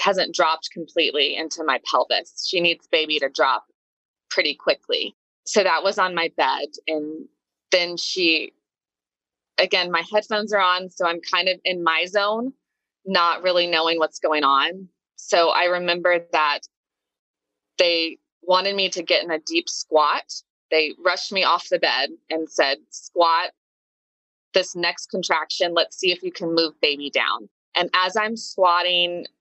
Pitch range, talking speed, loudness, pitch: 165-185 Hz, 155 wpm, -21 LUFS, 175 Hz